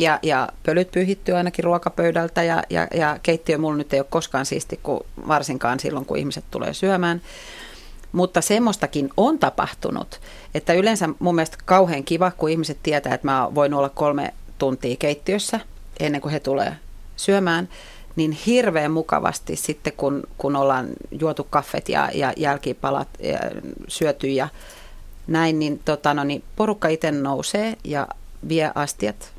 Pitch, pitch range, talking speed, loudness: 155 Hz, 145-175 Hz, 150 wpm, -22 LUFS